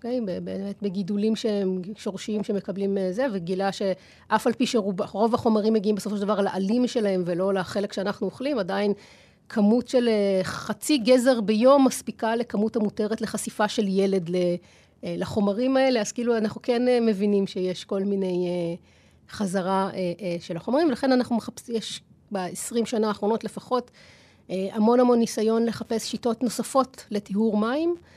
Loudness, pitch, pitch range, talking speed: -25 LUFS, 215 Hz, 195-235 Hz, 135 wpm